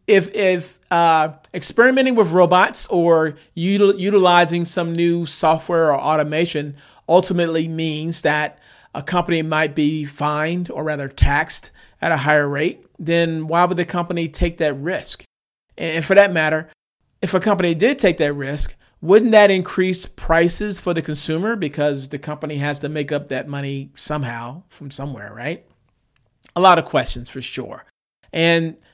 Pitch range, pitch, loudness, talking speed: 150-180 Hz, 165 Hz, -18 LUFS, 155 wpm